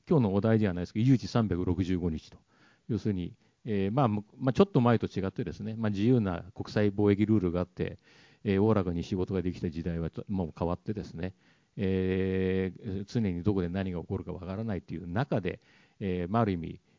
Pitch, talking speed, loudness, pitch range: 100 Hz, 385 characters per minute, -30 LUFS, 90-110 Hz